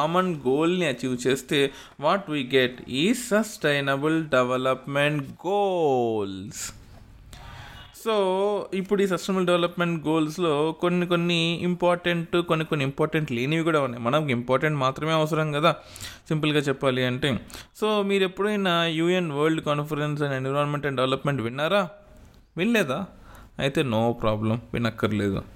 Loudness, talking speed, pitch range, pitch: -25 LUFS, 115 wpm, 130-175 Hz, 150 Hz